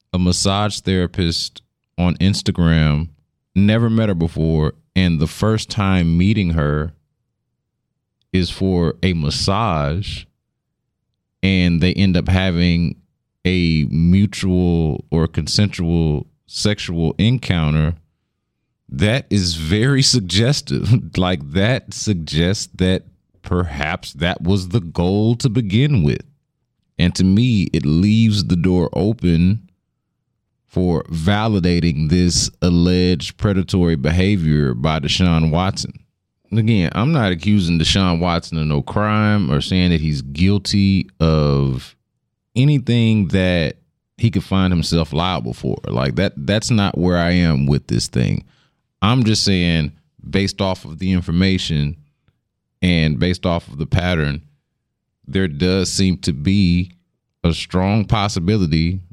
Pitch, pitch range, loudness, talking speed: 90 Hz, 85-105 Hz, -17 LUFS, 120 wpm